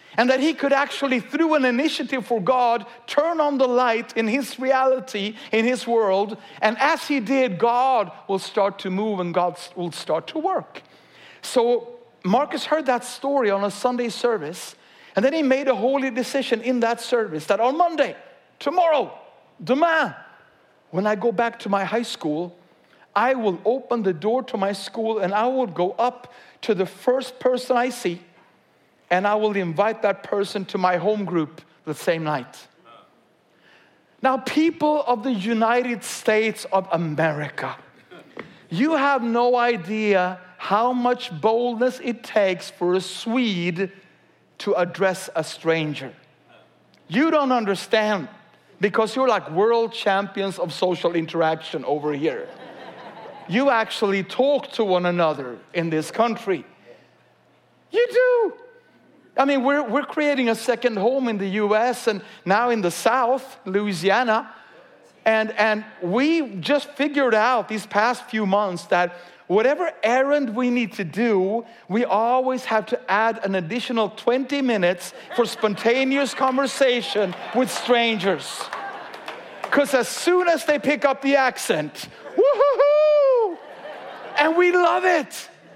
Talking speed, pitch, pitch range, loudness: 145 wpm, 230 Hz, 195-265 Hz, -22 LUFS